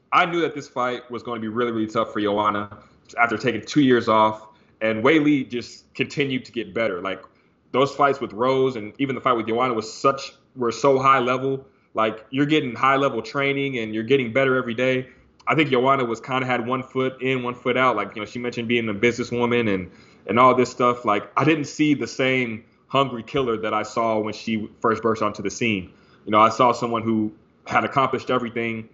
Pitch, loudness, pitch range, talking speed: 120 Hz, -22 LUFS, 110-130 Hz, 225 wpm